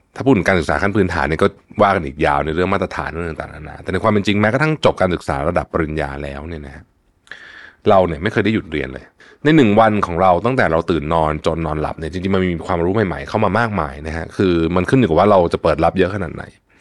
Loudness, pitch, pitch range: -17 LUFS, 85 Hz, 80-100 Hz